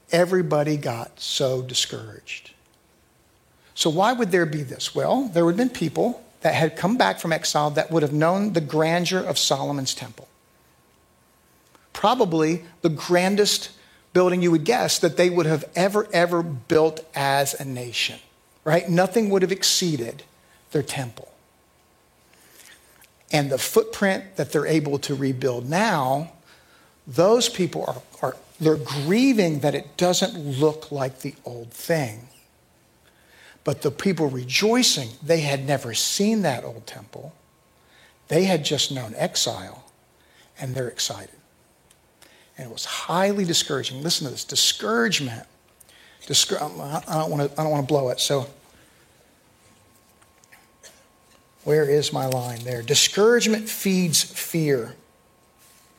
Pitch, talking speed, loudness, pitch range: 155 Hz, 135 wpm, -22 LUFS, 140-180 Hz